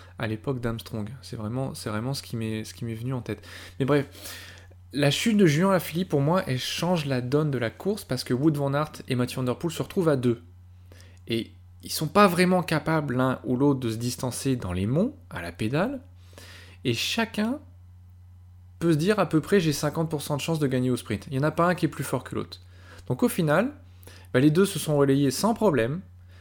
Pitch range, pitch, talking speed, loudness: 95-155 Hz, 130 Hz, 230 wpm, -26 LUFS